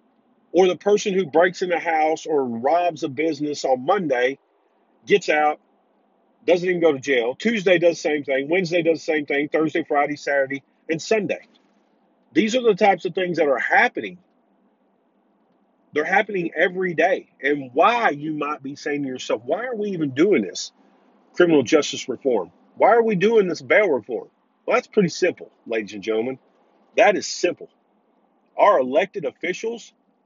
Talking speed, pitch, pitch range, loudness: 170 wpm, 165 Hz, 145-200 Hz, -21 LUFS